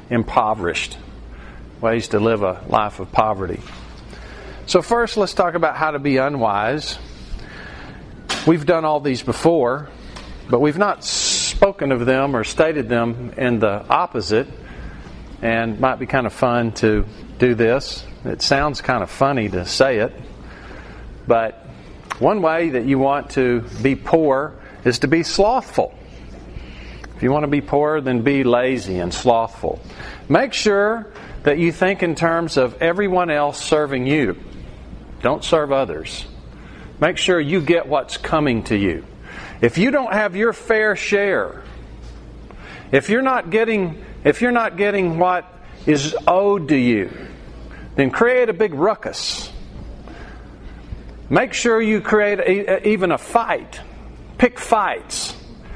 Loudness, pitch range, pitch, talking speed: -18 LUFS, 115-190 Hz, 145 Hz, 145 wpm